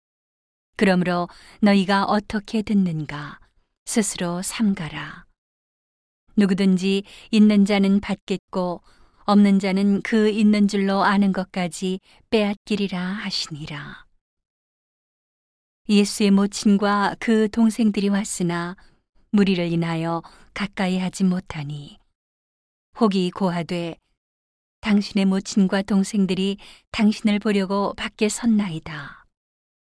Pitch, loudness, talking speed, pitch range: 195 Hz, -21 LUFS, 215 characters per minute, 180-205 Hz